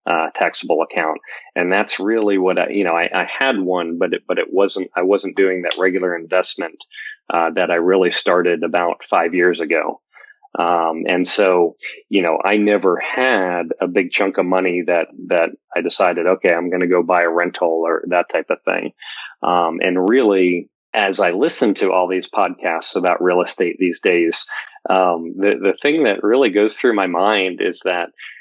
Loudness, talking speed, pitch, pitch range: -17 LUFS, 190 wpm, 90 Hz, 85-95 Hz